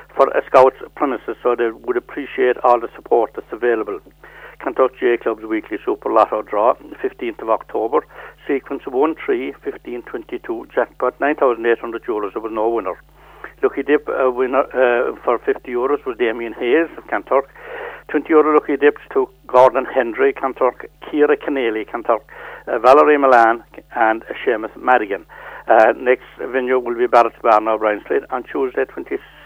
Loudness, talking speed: -18 LUFS, 155 wpm